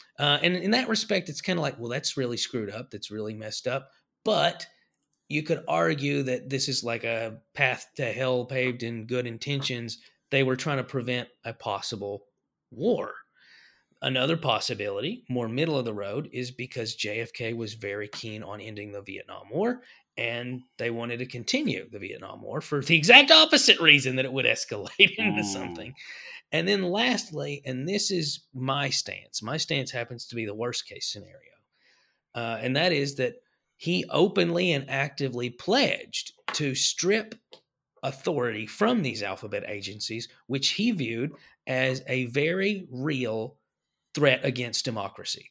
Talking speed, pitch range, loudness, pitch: 160 wpm, 115-150 Hz, -26 LUFS, 130 Hz